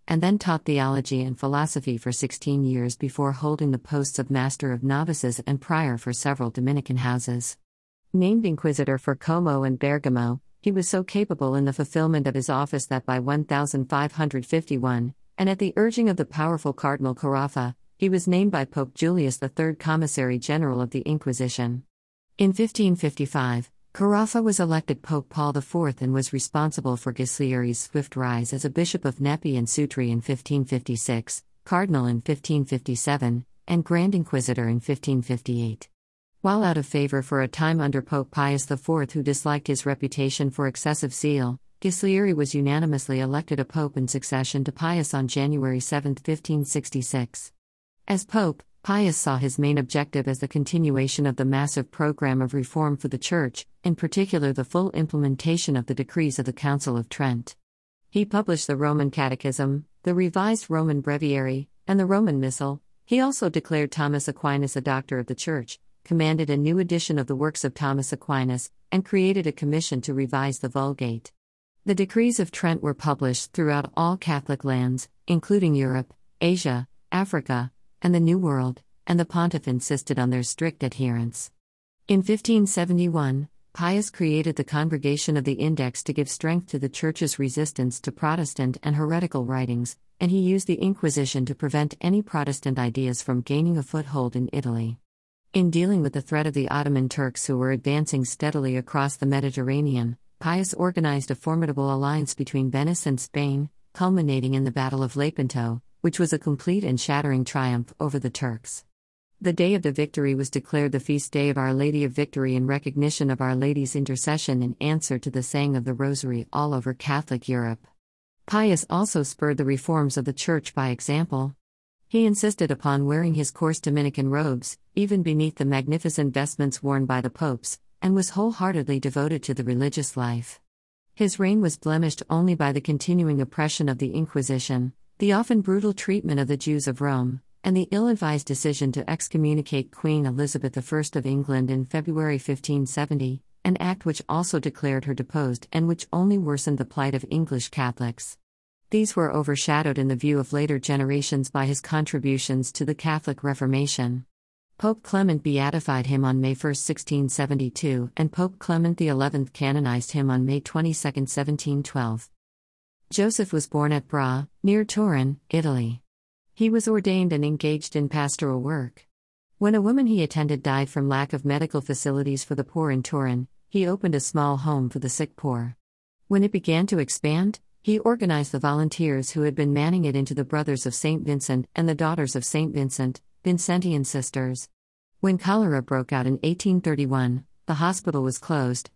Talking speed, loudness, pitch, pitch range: 170 wpm, -25 LUFS, 145 Hz, 130-160 Hz